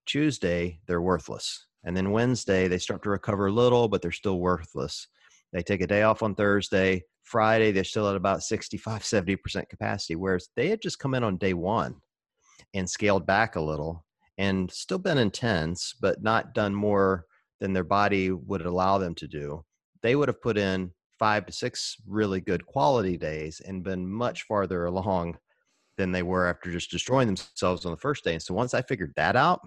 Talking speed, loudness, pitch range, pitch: 195 wpm, -27 LUFS, 90-105 Hz, 95 Hz